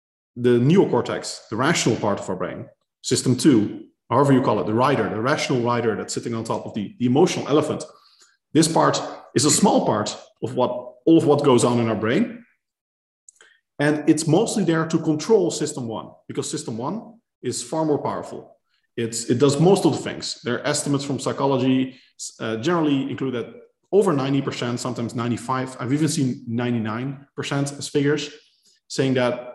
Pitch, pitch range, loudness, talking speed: 140 Hz, 120-155 Hz, -21 LUFS, 175 wpm